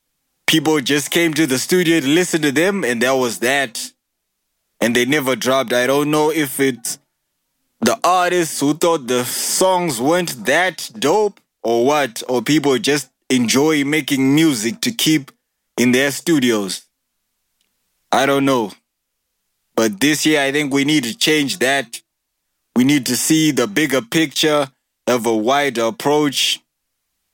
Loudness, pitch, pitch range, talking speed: -17 LUFS, 140 Hz, 125-155 Hz, 150 wpm